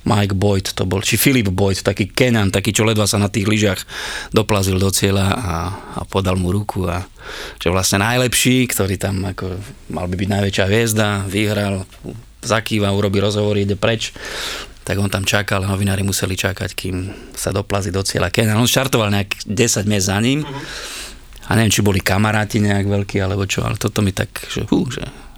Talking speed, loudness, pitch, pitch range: 185 wpm, -18 LUFS, 100 Hz, 95-110 Hz